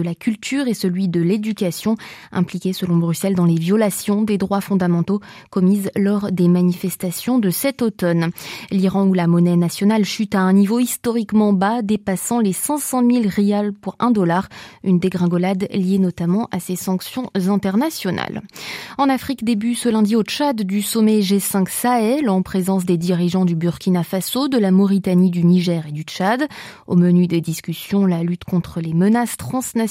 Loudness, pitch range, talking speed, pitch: -18 LUFS, 180-220 Hz, 175 wpm, 195 Hz